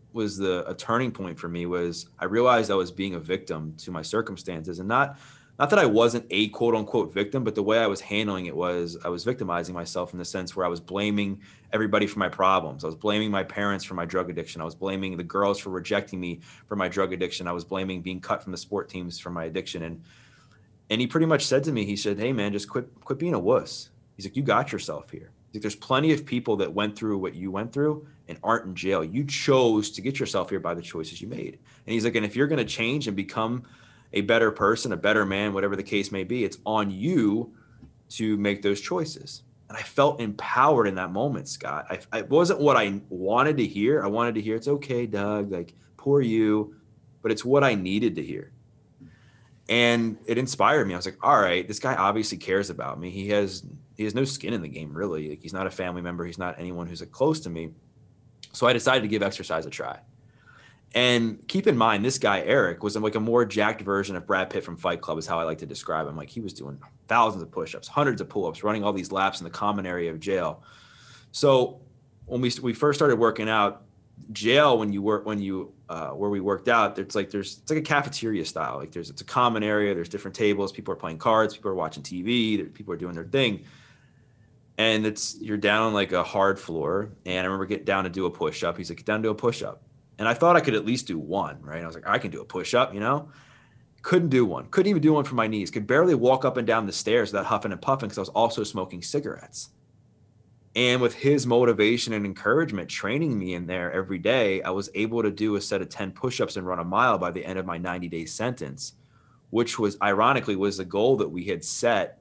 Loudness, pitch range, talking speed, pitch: -26 LUFS, 95-120 Hz, 245 wpm, 105 Hz